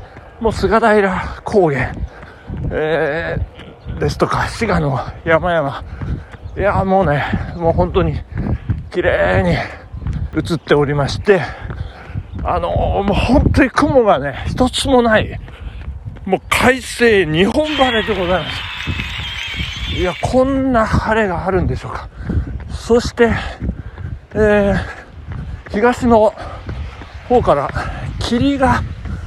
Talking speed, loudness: 195 characters per minute, -16 LUFS